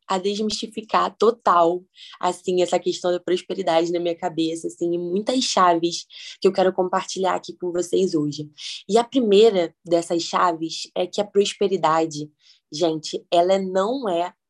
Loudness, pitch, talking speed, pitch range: -22 LUFS, 180 Hz, 145 wpm, 170-195 Hz